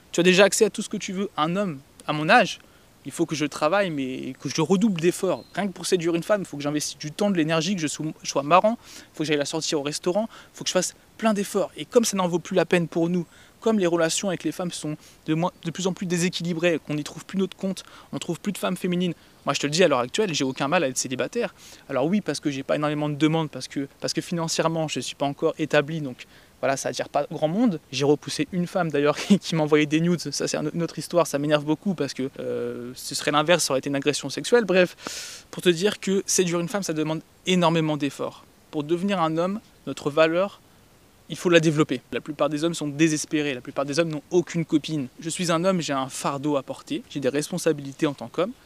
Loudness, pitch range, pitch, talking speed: -24 LUFS, 145-180 Hz, 160 Hz, 265 wpm